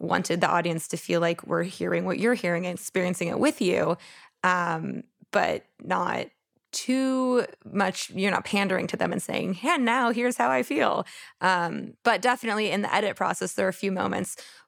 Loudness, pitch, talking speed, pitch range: -26 LUFS, 195 Hz, 190 wpm, 175-235 Hz